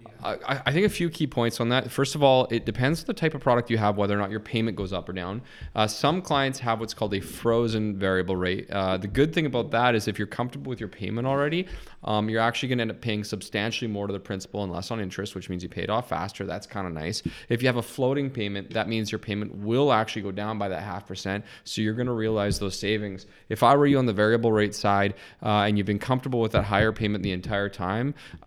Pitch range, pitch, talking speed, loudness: 100-120 Hz, 110 Hz, 270 wpm, -26 LUFS